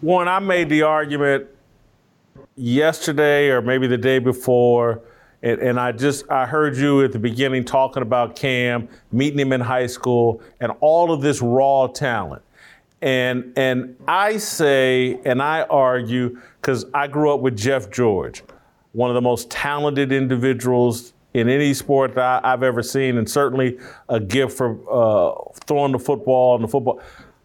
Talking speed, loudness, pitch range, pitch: 165 wpm, -19 LUFS, 125-140 Hz, 130 Hz